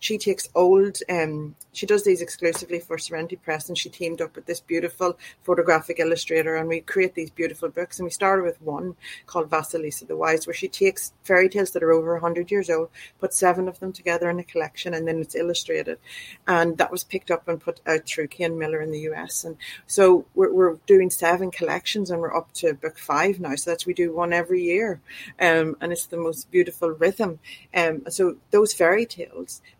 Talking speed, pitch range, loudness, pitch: 210 wpm, 165-185 Hz, -23 LUFS, 170 Hz